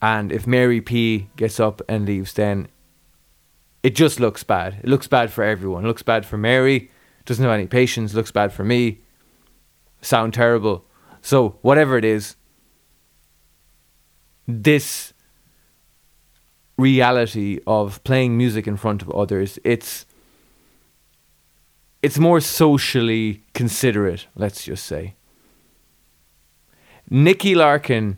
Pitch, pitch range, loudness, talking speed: 110 Hz, 80-120 Hz, -19 LUFS, 115 wpm